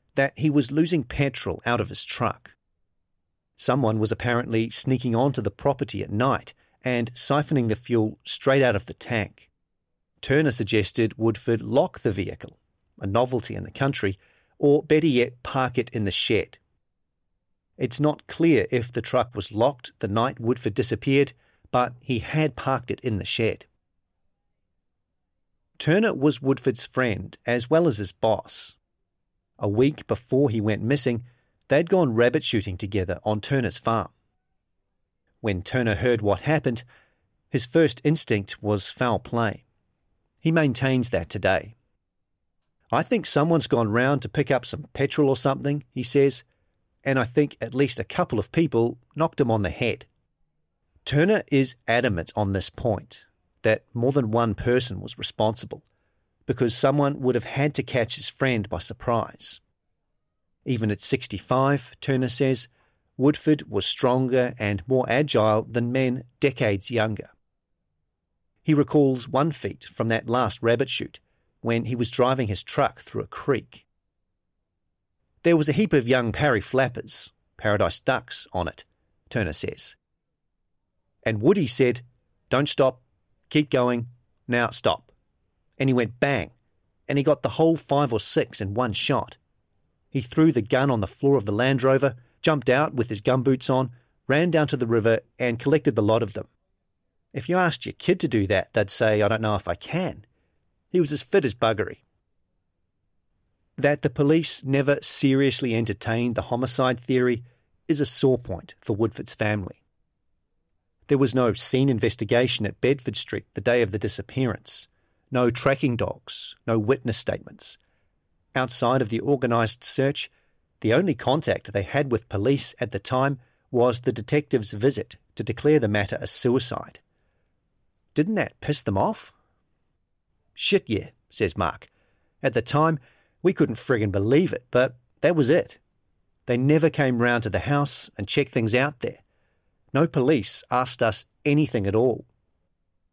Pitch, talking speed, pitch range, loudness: 120 Hz, 160 wpm, 105-135 Hz, -24 LUFS